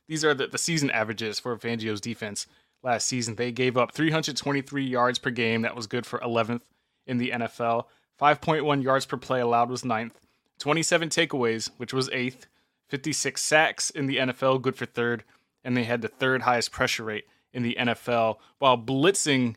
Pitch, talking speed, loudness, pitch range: 125 Hz, 180 wpm, -26 LUFS, 120-140 Hz